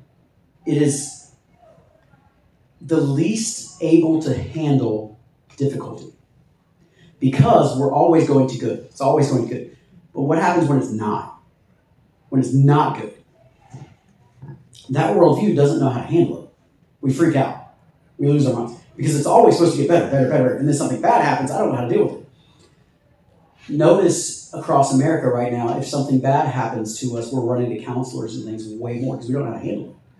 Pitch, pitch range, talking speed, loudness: 135 Hz, 120-150 Hz, 185 wpm, -19 LUFS